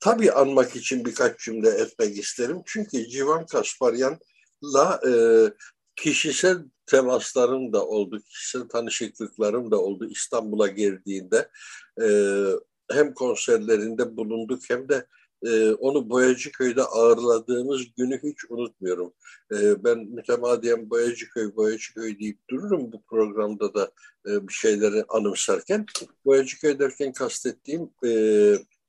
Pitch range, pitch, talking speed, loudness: 115-180 Hz, 130 Hz, 115 wpm, -24 LUFS